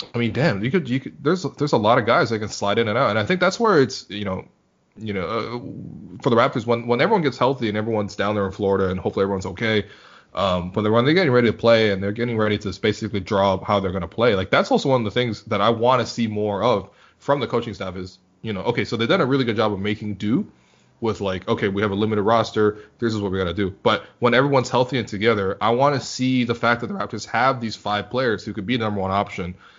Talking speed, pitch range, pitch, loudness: 280 wpm, 100-125 Hz, 110 Hz, -21 LUFS